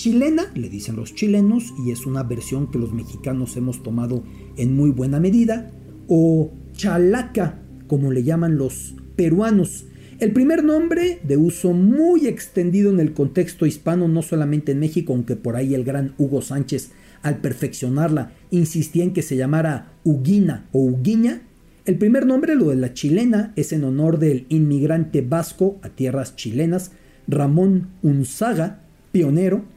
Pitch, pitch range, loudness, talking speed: 160 Hz, 135-190 Hz, -20 LUFS, 155 wpm